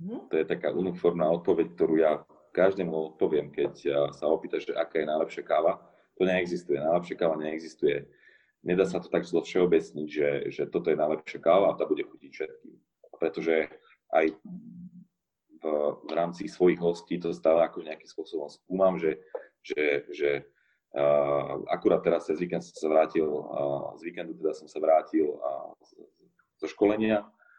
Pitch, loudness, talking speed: 85 Hz, -28 LUFS, 160 wpm